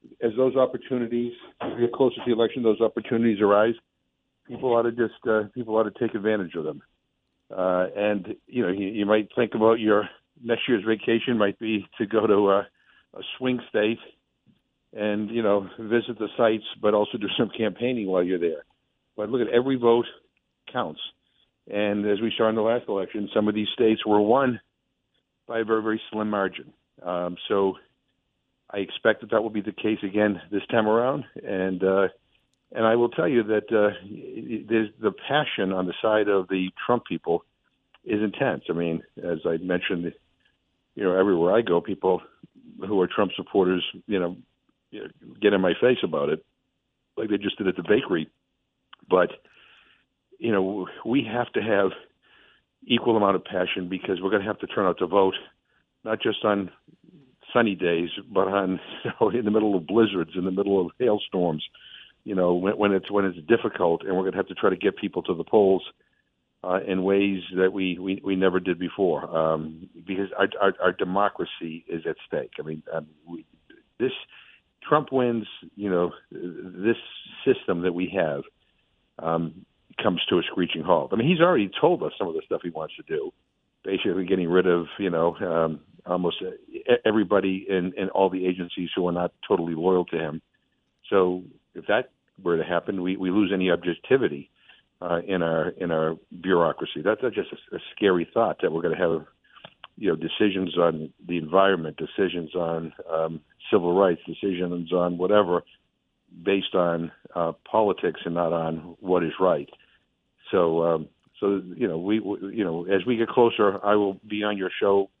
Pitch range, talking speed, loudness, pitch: 90-110 Hz, 185 wpm, -25 LUFS, 100 Hz